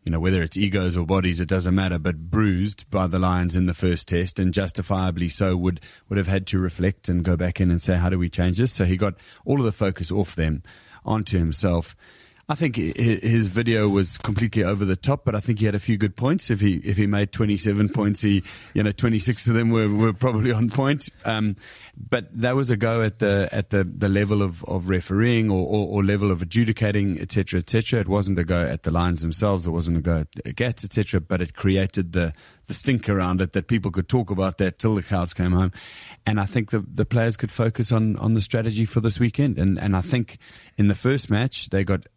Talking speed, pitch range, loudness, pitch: 245 wpm, 90-115 Hz, -22 LUFS, 100 Hz